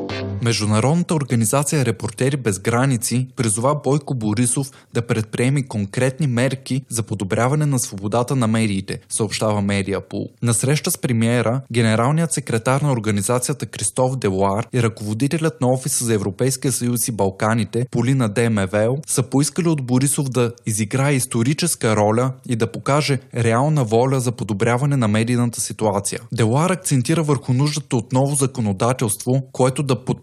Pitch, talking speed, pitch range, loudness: 125 Hz, 135 wpm, 115-135 Hz, -19 LUFS